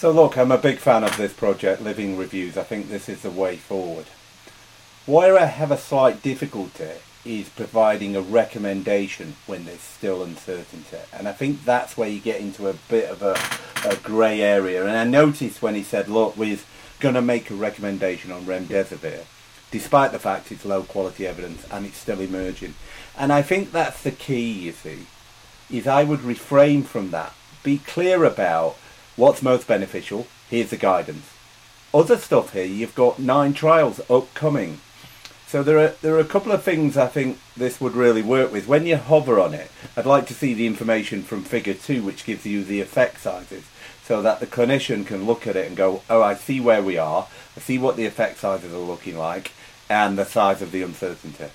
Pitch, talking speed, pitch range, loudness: 115 Hz, 200 wpm, 100-140 Hz, -21 LUFS